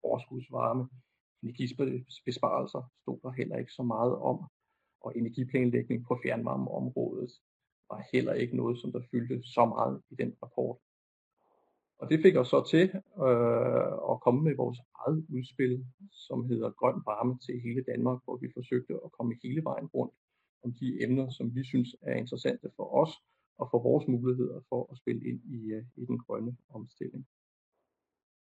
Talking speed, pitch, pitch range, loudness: 160 wpm, 125 Hz, 120-130 Hz, -32 LUFS